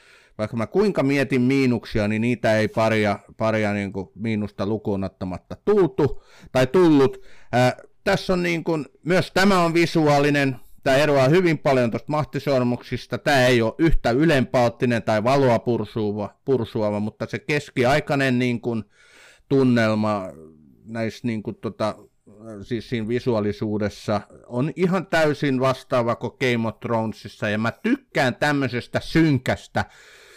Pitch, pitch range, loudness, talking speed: 120 Hz, 110-140 Hz, -22 LUFS, 130 wpm